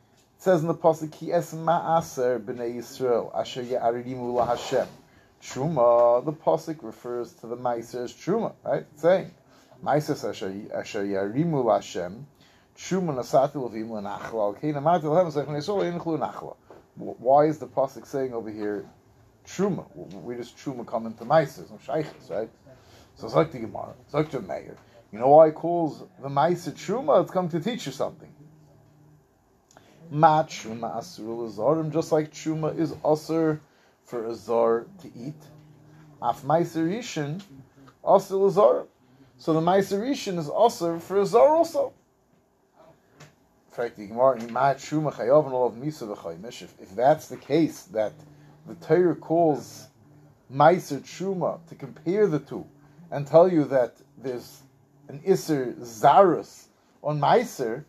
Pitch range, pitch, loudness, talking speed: 120-165 Hz, 145 Hz, -25 LUFS, 140 wpm